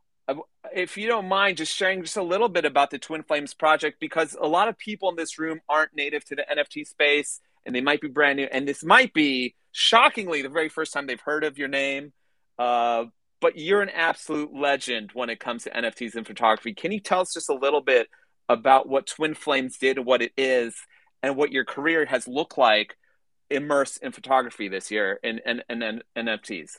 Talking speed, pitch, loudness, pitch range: 215 wpm, 145 Hz, -24 LUFS, 130-165 Hz